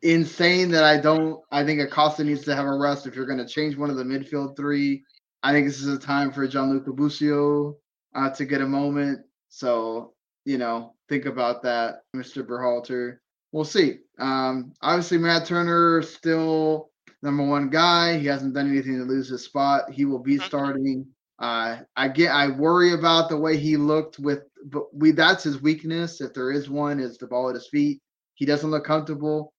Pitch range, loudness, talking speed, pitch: 135-155 Hz, -23 LUFS, 195 wpm, 145 Hz